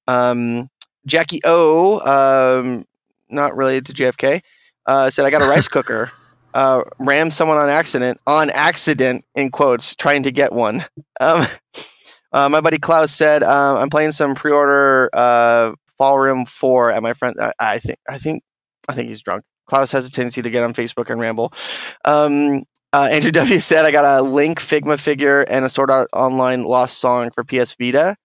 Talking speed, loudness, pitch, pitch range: 185 wpm, -16 LUFS, 135 Hz, 125-145 Hz